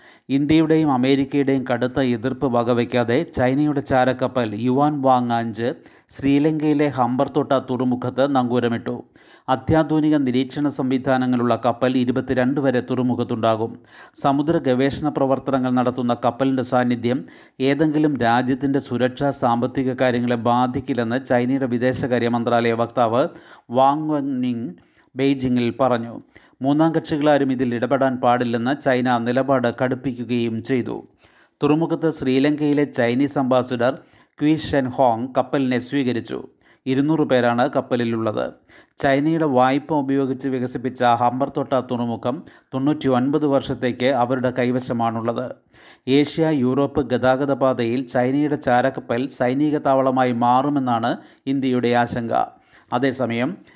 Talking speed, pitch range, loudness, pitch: 95 wpm, 125-140 Hz, -20 LUFS, 130 Hz